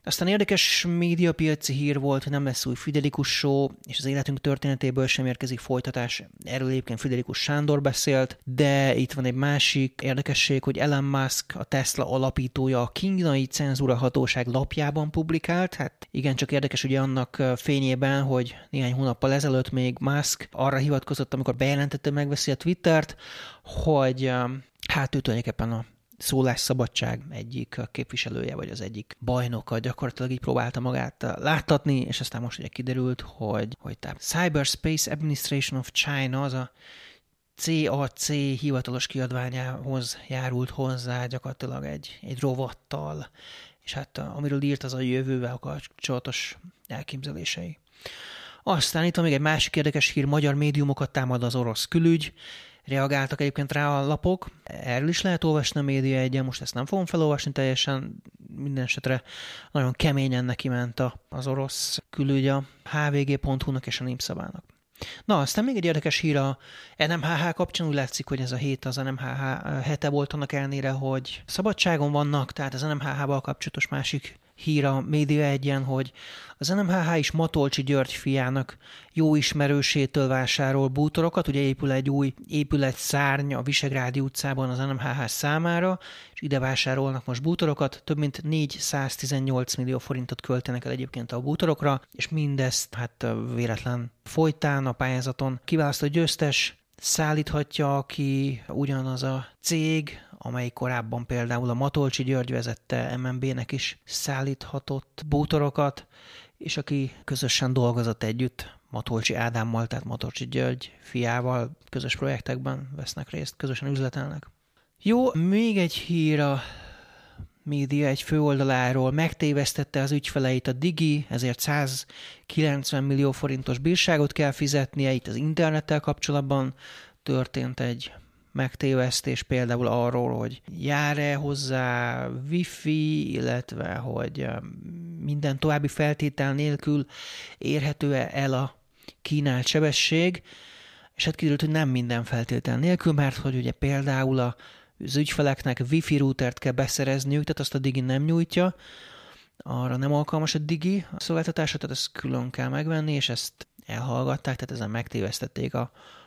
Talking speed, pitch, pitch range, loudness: 135 wpm, 135 Hz, 130-150 Hz, -26 LUFS